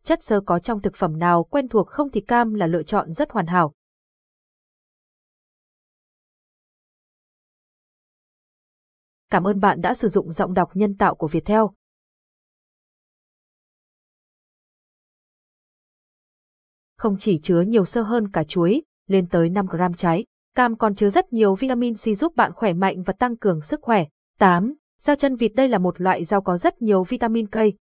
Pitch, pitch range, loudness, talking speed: 205 Hz, 180-235 Hz, -21 LUFS, 155 wpm